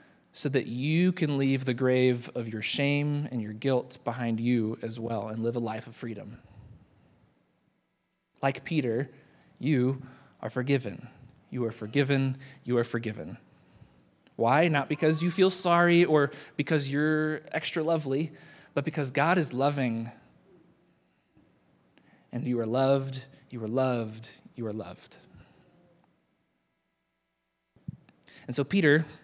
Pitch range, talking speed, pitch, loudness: 115-145 Hz, 130 wpm, 135 Hz, -28 LUFS